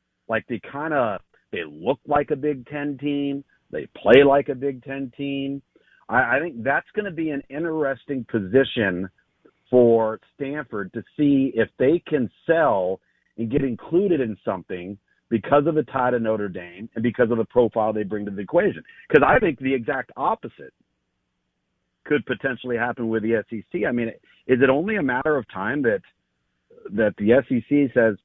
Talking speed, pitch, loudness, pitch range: 180 wpm, 125 Hz, -22 LUFS, 110-140 Hz